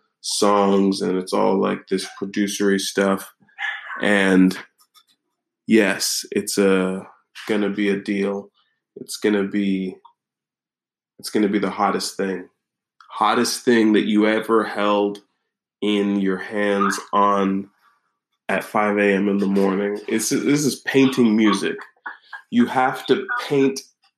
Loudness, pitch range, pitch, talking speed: -20 LUFS, 100-110 Hz, 100 Hz, 125 wpm